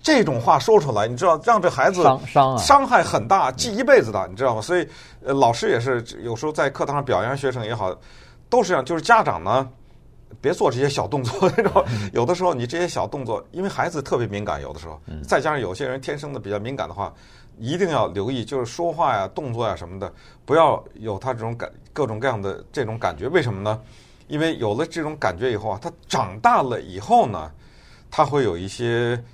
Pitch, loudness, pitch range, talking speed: 130 Hz, -21 LUFS, 110-165 Hz, 325 characters per minute